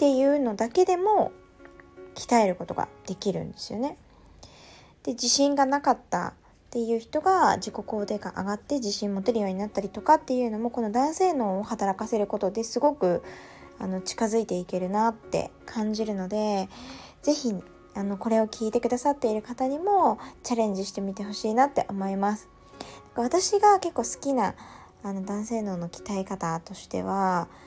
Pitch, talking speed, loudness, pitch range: 220 Hz, 350 characters per minute, -27 LUFS, 195-255 Hz